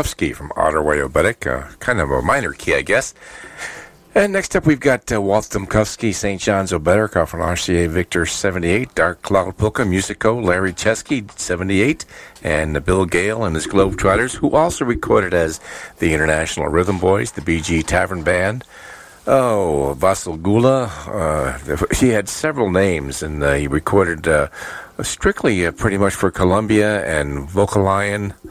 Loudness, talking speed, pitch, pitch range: -18 LUFS, 150 wpm, 95 Hz, 85-110 Hz